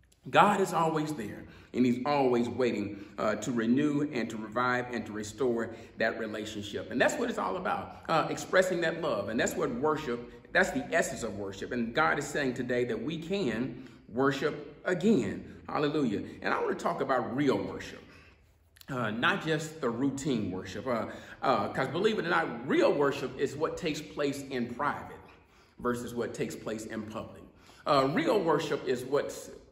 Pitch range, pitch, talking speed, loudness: 110-155 Hz, 125 Hz, 180 wpm, -31 LUFS